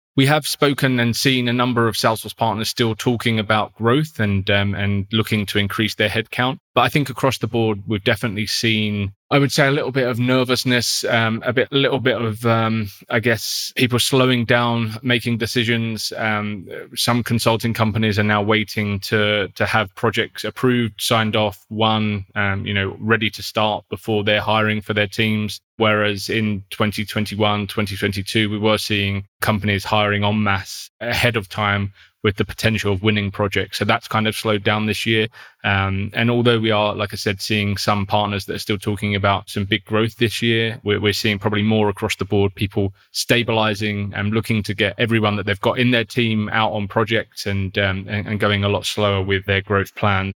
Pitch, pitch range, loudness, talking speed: 110 Hz, 105-115 Hz, -19 LUFS, 200 wpm